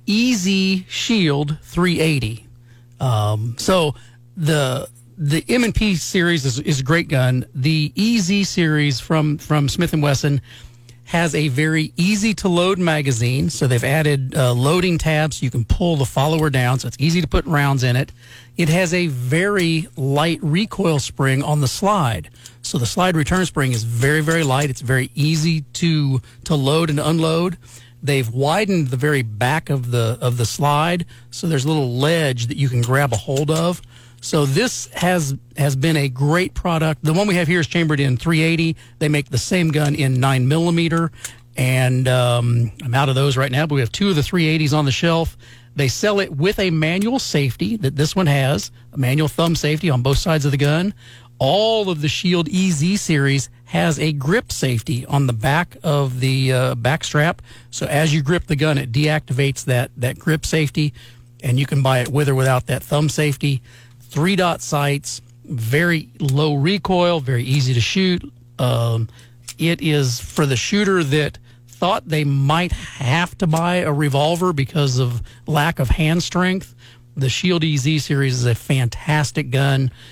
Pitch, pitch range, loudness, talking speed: 145 Hz, 125-165 Hz, -18 LUFS, 180 wpm